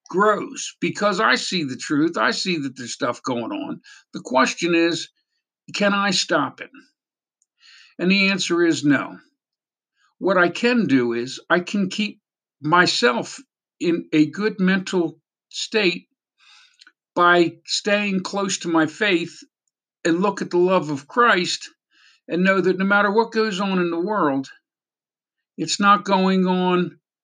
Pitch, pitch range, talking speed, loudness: 185 Hz, 170-210 Hz, 150 wpm, -20 LUFS